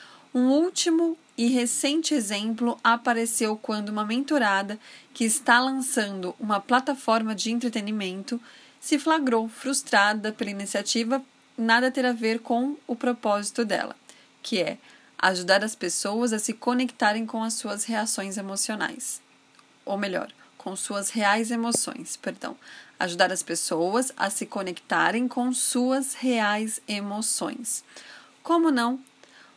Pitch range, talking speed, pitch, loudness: 205-255 Hz, 125 wpm, 230 Hz, -25 LUFS